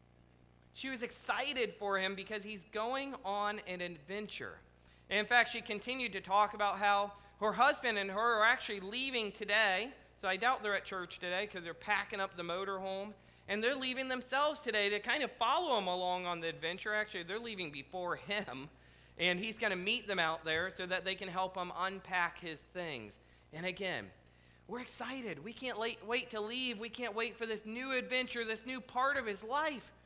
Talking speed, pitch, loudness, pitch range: 200 wpm, 205 Hz, -36 LUFS, 185-235 Hz